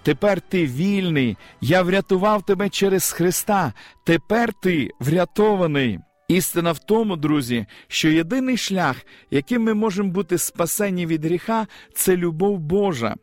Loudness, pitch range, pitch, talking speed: -21 LUFS, 155-200 Hz, 180 Hz, 125 wpm